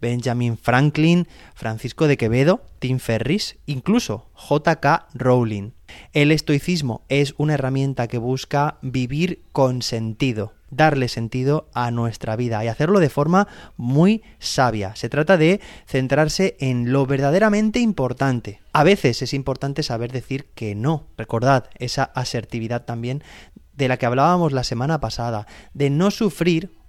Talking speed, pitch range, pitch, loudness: 135 wpm, 120-155 Hz, 135 Hz, -20 LUFS